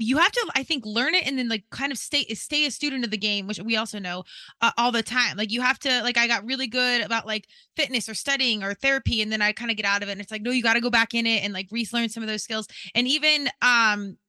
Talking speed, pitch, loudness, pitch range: 305 wpm, 230 Hz, -23 LUFS, 215-260 Hz